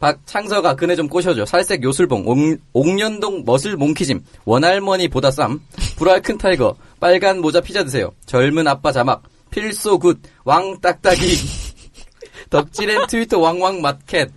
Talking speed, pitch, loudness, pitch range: 290 characters per minute, 180 Hz, -17 LUFS, 150-195 Hz